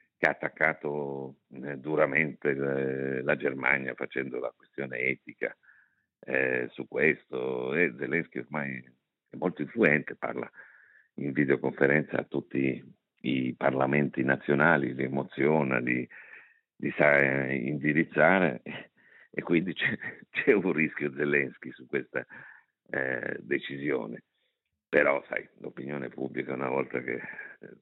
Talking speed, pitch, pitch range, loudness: 110 wpm, 65 Hz, 65-70 Hz, -29 LUFS